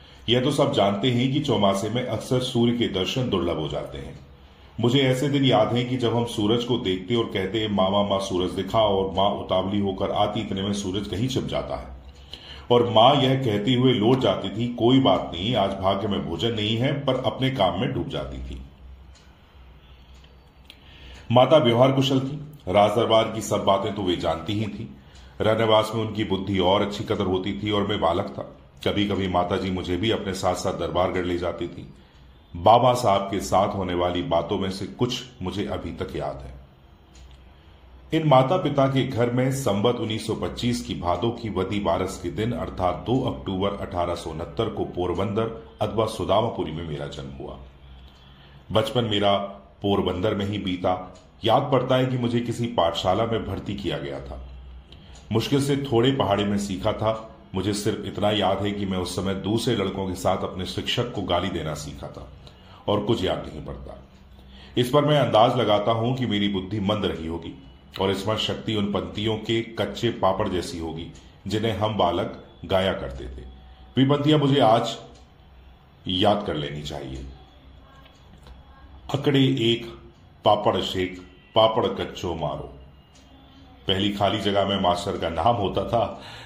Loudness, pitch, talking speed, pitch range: -24 LUFS, 100 Hz, 175 wpm, 80-115 Hz